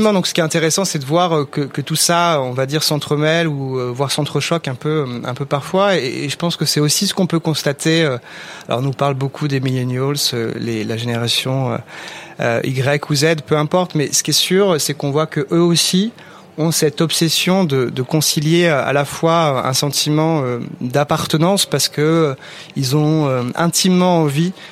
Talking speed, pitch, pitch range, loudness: 185 wpm, 150 Hz, 140-165 Hz, -16 LUFS